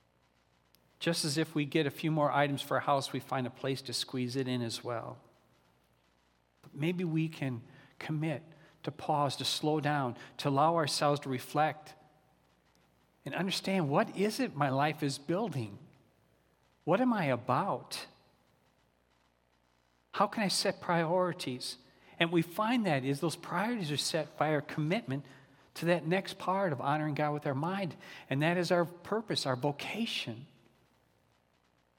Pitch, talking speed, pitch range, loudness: 150 Hz, 160 wpm, 130-170 Hz, -33 LUFS